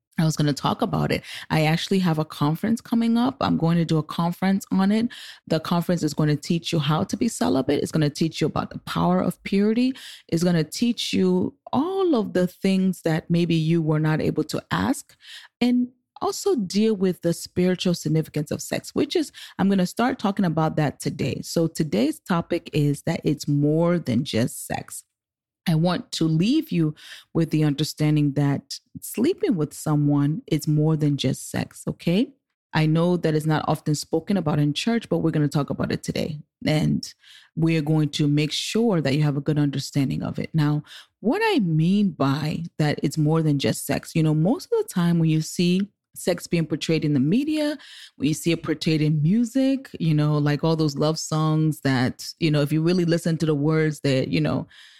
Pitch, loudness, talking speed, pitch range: 165 Hz, -23 LUFS, 210 wpm, 150-195 Hz